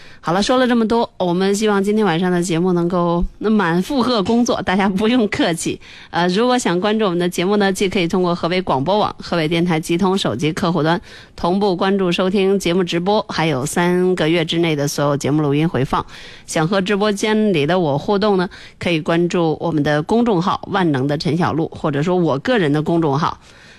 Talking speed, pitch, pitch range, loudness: 325 characters per minute, 180 Hz, 165-205 Hz, -17 LUFS